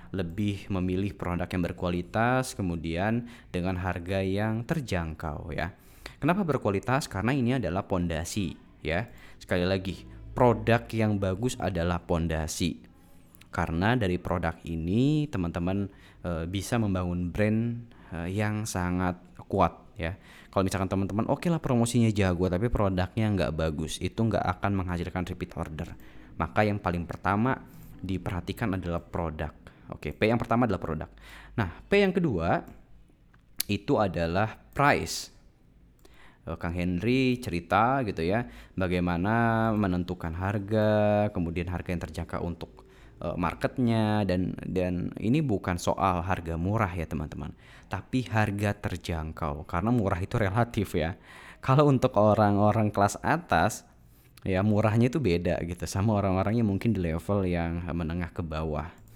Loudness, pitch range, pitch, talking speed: -28 LUFS, 85-110 Hz, 95 Hz, 130 wpm